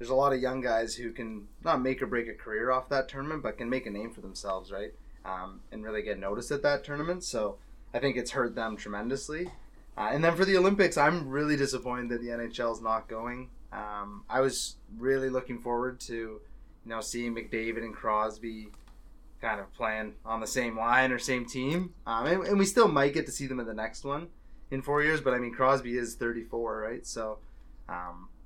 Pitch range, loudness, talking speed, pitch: 110-135 Hz, -31 LUFS, 220 wpm, 120 Hz